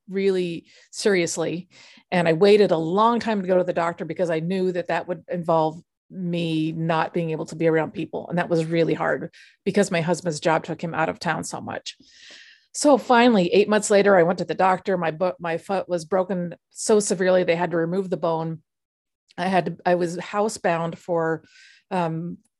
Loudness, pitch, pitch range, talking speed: -22 LUFS, 175 Hz, 165-190 Hz, 200 wpm